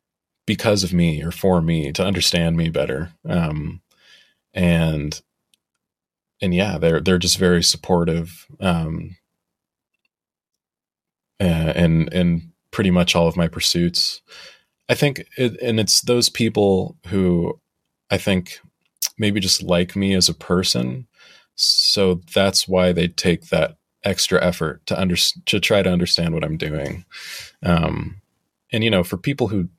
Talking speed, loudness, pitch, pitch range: 140 wpm, -19 LUFS, 90 Hz, 85-95 Hz